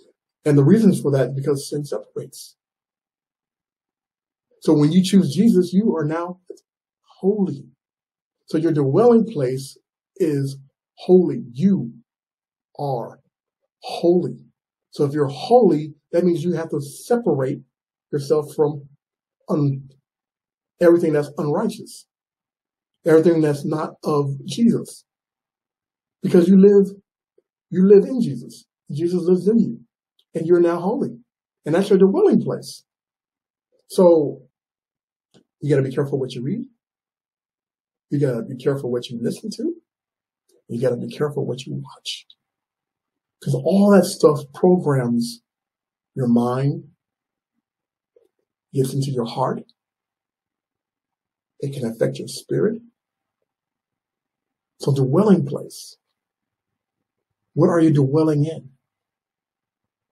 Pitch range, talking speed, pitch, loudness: 140-195 Hz, 120 wpm, 160 Hz, -19 LUFS